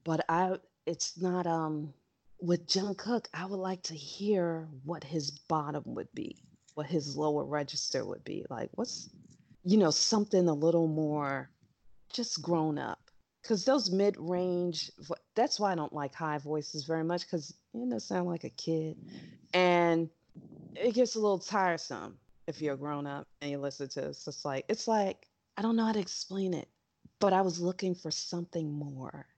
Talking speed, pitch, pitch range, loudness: 180 wpm, 170 Hz, 150-190 Hz, -33 LUFS